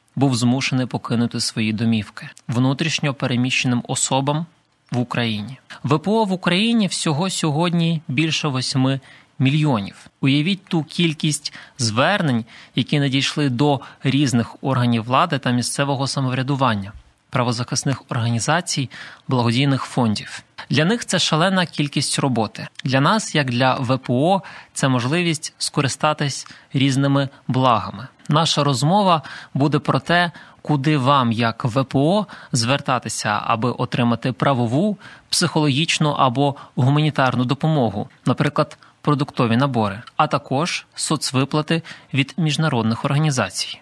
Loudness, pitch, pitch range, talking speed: -20 LUFS, 140 Hz, 125-155 Hz, 105 wpm